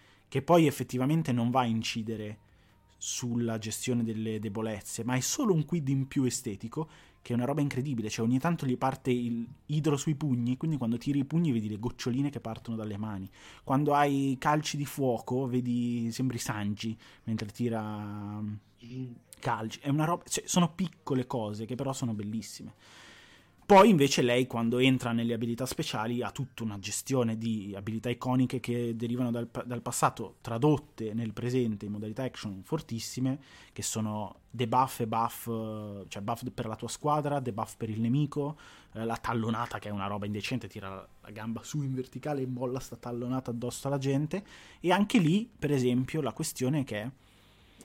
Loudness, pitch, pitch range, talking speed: -31 LUFS, 120 Hz, 110-135 Hz, 175 wpm